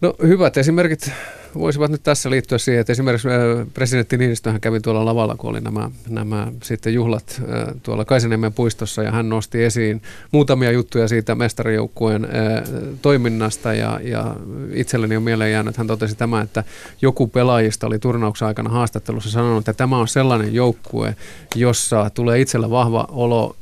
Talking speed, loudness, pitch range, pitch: 160 wpm, -19 LUFS, 110-125 Hz, 115 Hz